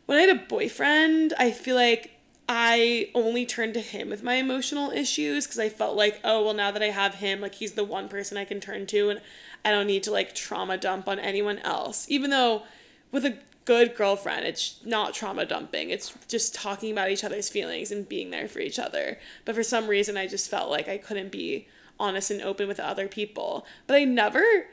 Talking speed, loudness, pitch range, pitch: 220 wpm, -26 LUFS, 200-250 Hz, 215 Hz